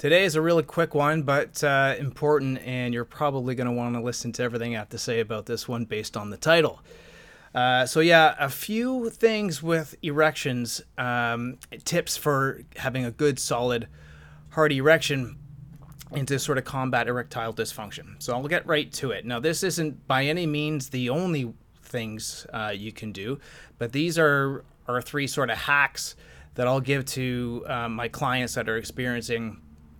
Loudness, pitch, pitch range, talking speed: -26 LUFS, 130 Hz, 120-150 Hz, 180 wpm